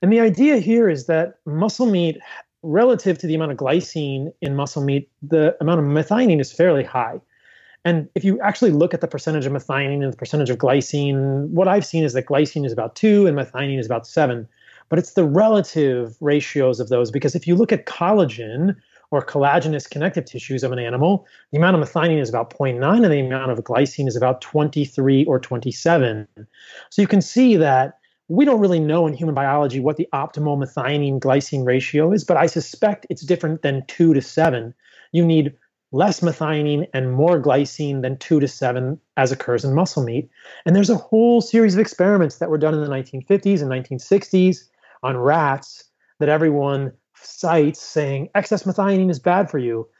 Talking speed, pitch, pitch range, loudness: 195 wpm, 150 Hz, 135-175 Hz, -19 LUFS